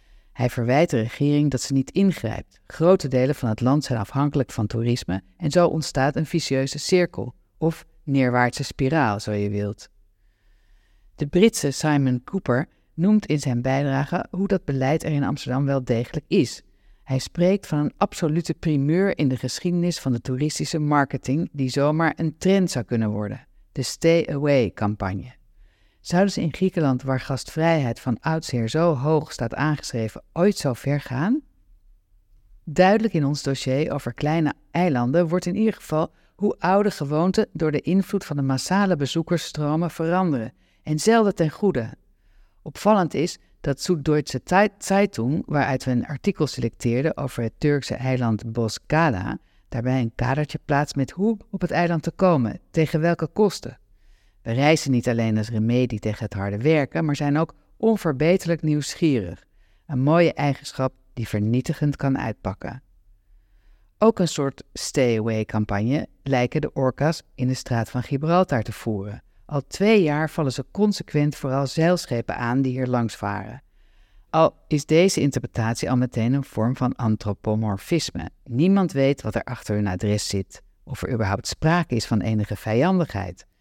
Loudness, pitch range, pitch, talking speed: -23 LUFS, 115-160 Hz, 135 Hz, 155 wpm